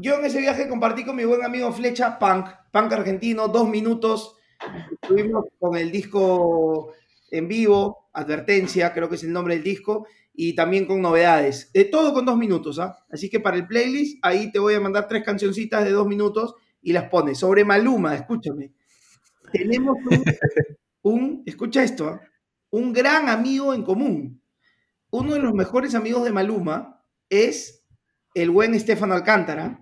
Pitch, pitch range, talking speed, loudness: 210 Hz, 175-235 Hz, 165 wpm, -21 LUFS